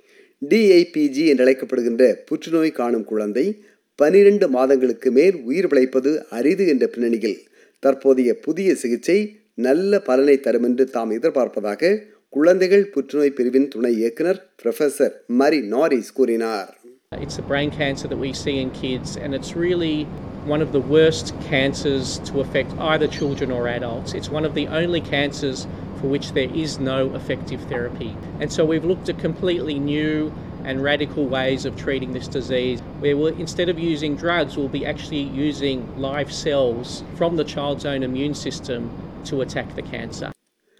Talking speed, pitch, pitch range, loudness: 130 wpm, 140 Hz, 130-160 Hz, -20 LUFS